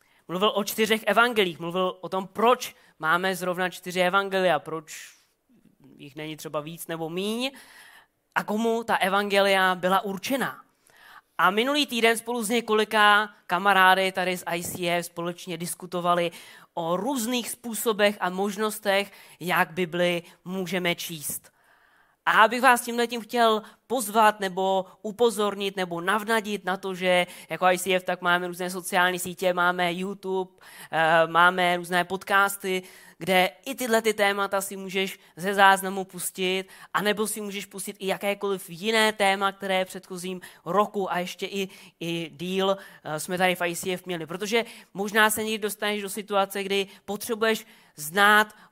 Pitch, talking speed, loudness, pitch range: 190 Hz, 140 wpm, -25 LUFS, 180-210 Hz